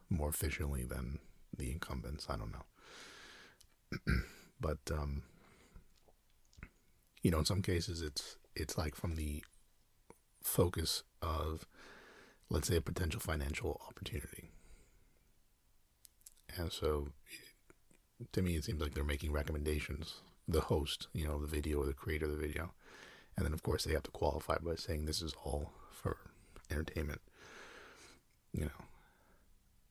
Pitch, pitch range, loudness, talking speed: 80 Hz, 75-90 Hz, -40 LUFS, 135 wpm